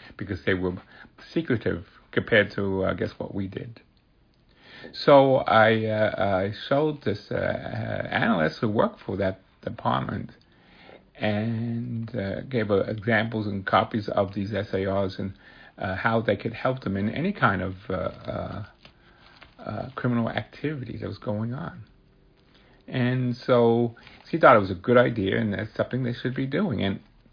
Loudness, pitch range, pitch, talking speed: -25 LUFS, 100-120 Hz, 110 Hz, 160 wpm